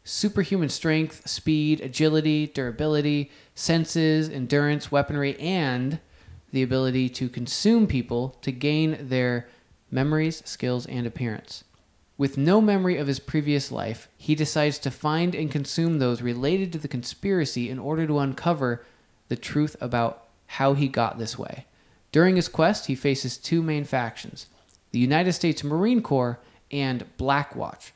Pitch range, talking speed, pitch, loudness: 125-155 Hz, 140 wpm, 140 Hz, -25 LUFS